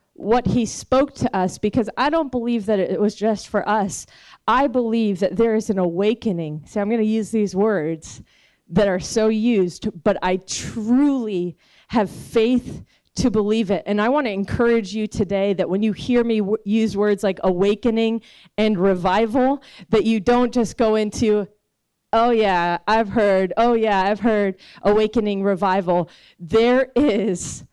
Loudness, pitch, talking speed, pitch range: -20 LUFS, 215 Hz, 170 wpm, 195-230 Hz